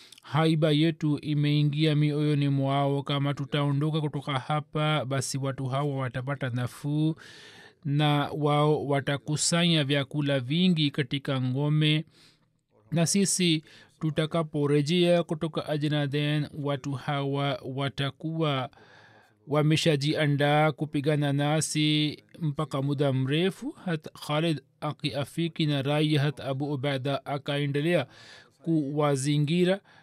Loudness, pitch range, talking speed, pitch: -27 LUFS, 140-155 Hz, 90 wpm, 150 Hz